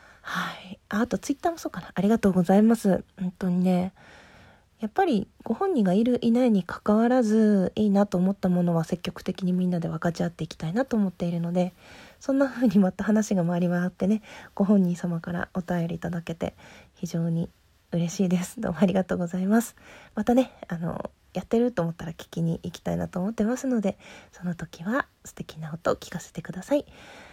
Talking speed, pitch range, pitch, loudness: 400 characters per minute, 175-220 Hz, 185 Hz, -26 LUFS